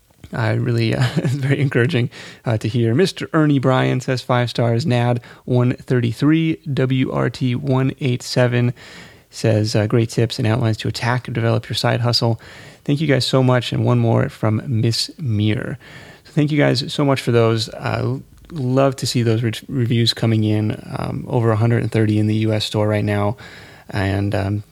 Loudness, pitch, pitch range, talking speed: -19 LUFS, 120 Hz, 115-130 Hz, 175 wpm